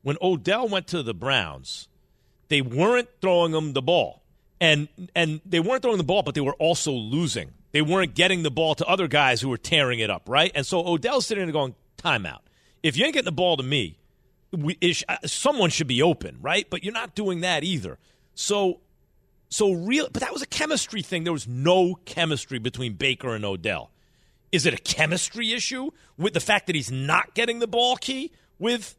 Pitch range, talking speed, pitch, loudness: 140-195 Hz, 205 wpm, 170 Hz, -24 LUFS